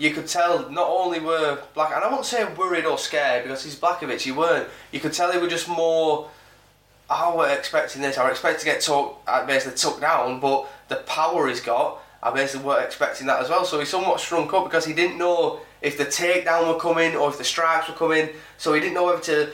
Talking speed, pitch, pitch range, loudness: 245 wpm, 160 Hz, 145-175 Hz, -22 LUFS